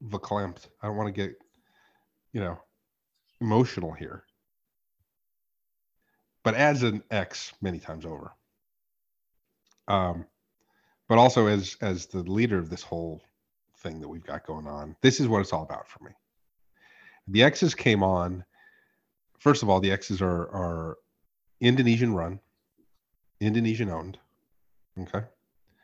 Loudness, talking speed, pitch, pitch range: -26 LUFS, 130 wpm, 95 Hz, 90-110 Hz